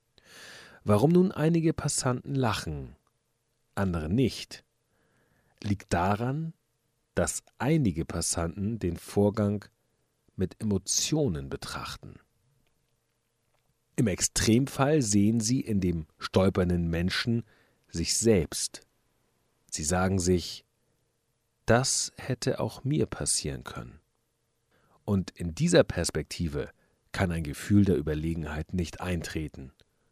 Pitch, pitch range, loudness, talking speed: 105 Hz, 90-120 Hz, -28 LUFS, 95 wpm